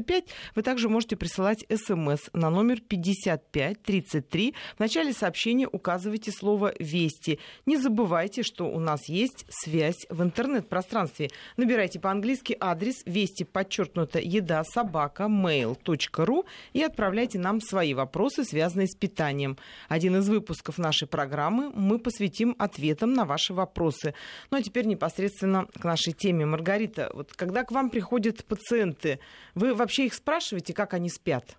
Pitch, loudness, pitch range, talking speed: 195 Hz, -28 LUFS, 165-230 Hz, 135 wpm